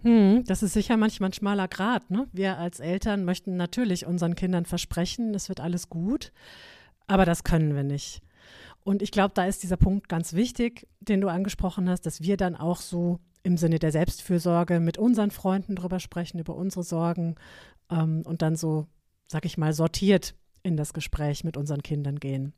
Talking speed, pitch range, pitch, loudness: 185 wpm, 165-195 Hz, 180 Hz, -27 LUFS